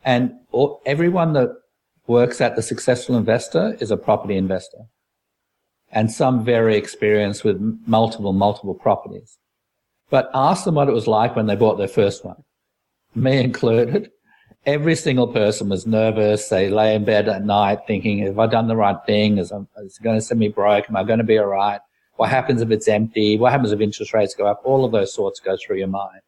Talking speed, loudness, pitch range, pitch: 200 wpm, -19 LUFS, 105-125 Hz, 110 Hz